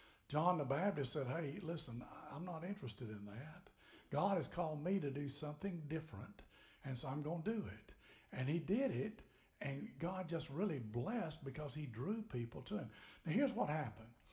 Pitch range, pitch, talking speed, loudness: 135-185 Hz, 155 Hz, 190 wpm, -43 LUFS